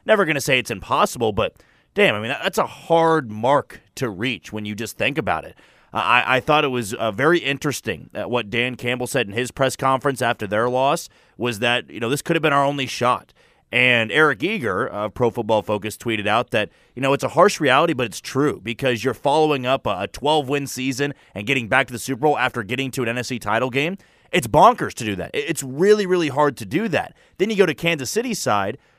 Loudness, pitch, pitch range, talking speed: -20 LUFS, 130 Hz, 120-145 Hz, 240 wpm